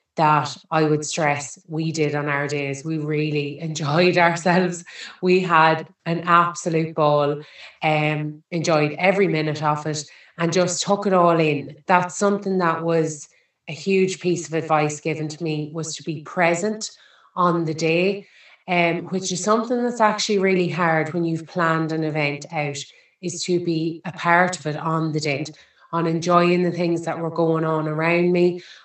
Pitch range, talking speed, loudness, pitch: 155-175 Hz, 175 wpm, -21 LUFS, 165 Hz